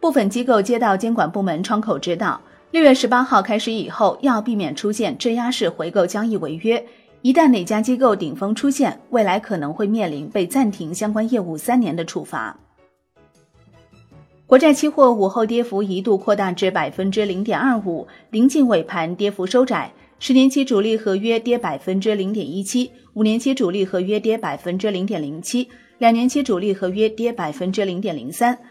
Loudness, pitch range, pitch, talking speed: -19 LUFS, 190-245 Hz, 215 Hz, 290 characters per minute